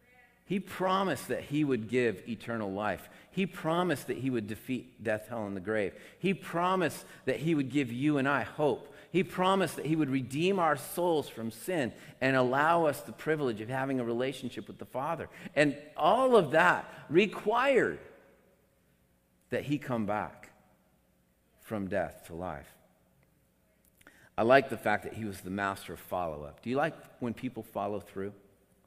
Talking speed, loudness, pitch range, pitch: 175 wpm, -31 LUFS, 110-160 Hz, 130 Hz